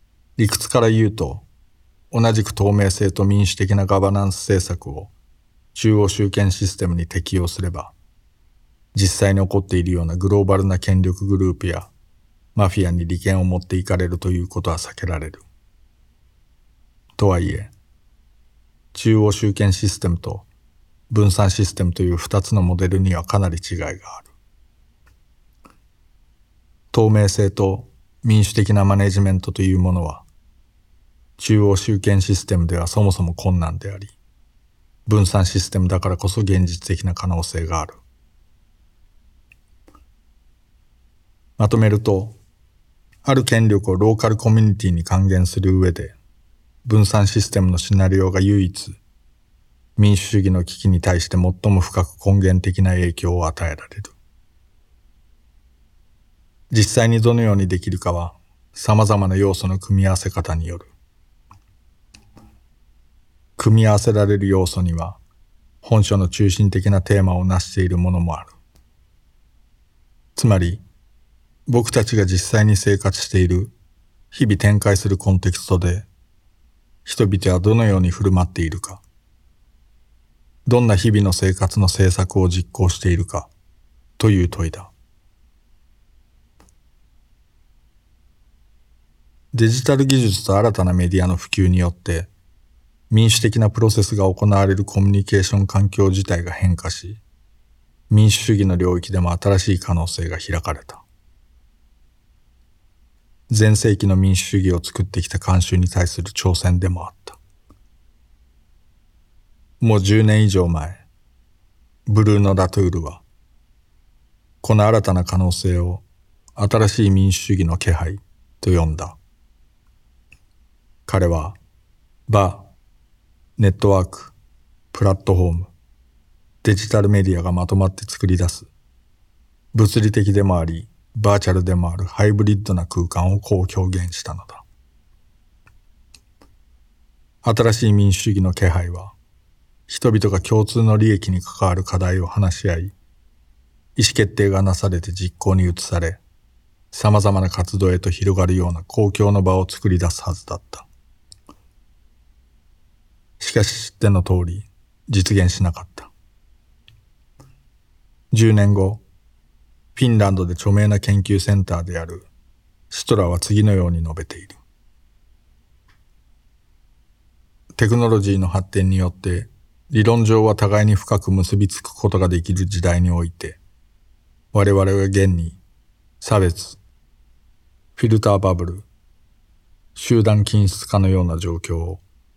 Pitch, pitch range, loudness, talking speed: 95 Hz, 85-100 Hz, -18 LUFS, 255 characters per minute